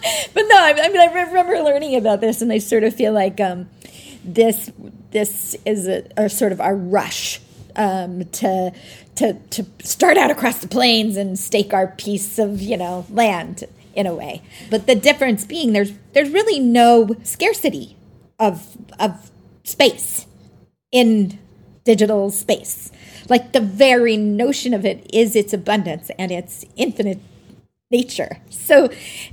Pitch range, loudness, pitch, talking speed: 200-250 Hz, -17 LUFS, 220 Hz, 150 wpm